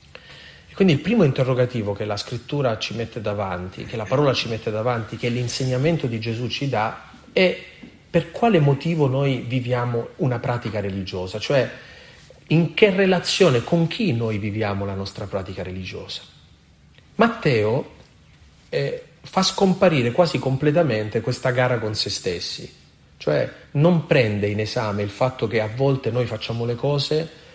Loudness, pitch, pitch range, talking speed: -22 LUFS, 120 Hz, 110-150 Hz, 150 wpm